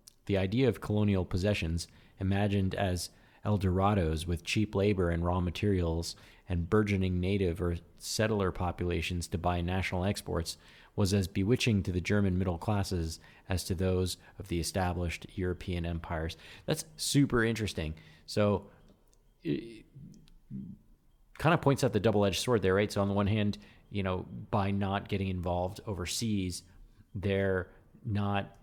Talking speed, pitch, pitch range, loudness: 145 wpm, 95 Hz, 90-105 Hz, -32 LUFS